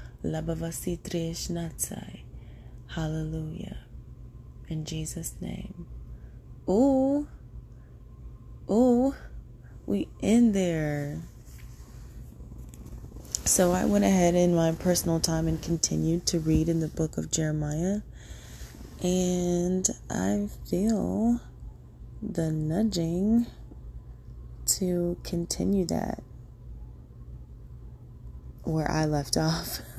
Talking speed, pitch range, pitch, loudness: 75 wpm, 145-180 Hz, 165 Hz, -27 LUFS